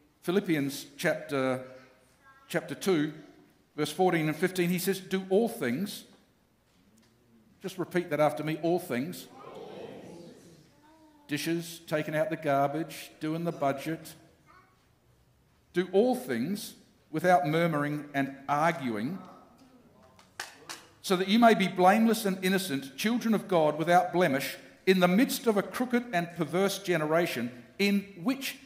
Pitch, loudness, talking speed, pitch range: 175 Hz, -29 LUFS, 125 wpm, 150-195 Hz